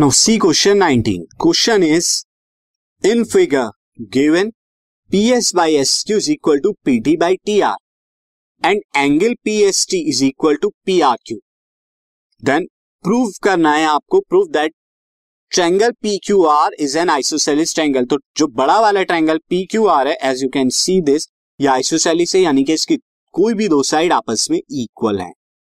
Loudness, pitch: -15 LUFS, 200 Hz